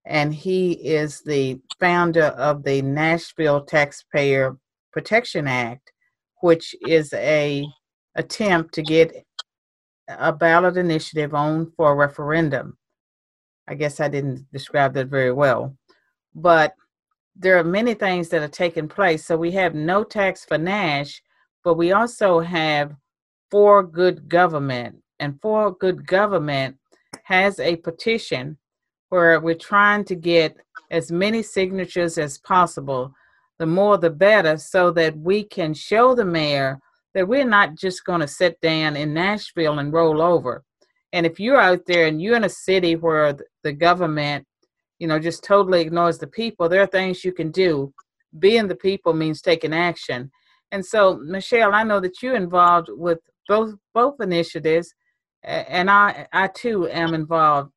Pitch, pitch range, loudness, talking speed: 170 Hz, 150-190 Hz, -20 LUFS, 150 wpm